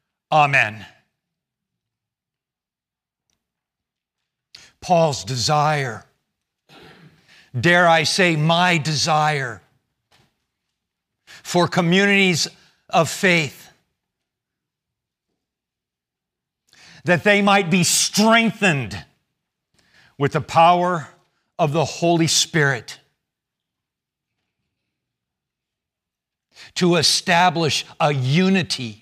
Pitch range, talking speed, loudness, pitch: 140-180 Hz, 60 wpm, -17 LUFS, 165 Hz